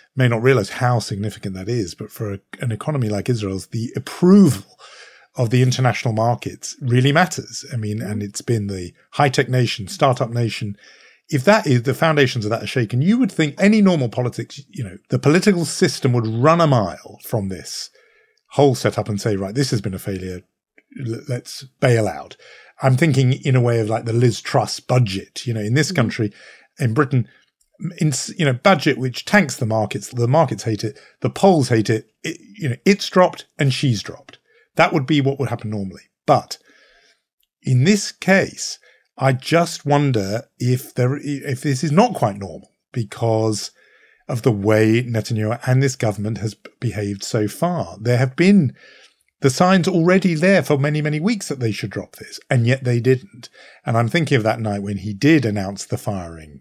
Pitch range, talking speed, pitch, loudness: 110-150 Hz, 190 wpm, 125 Hz, -19 LUFS